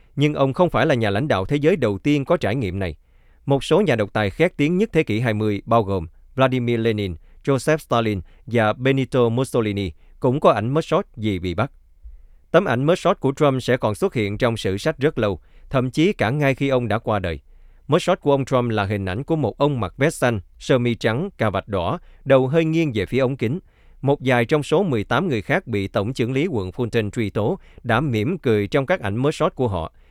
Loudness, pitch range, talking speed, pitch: -21 LUFS, 100-140 Hz, 235 wpm, 120 Hz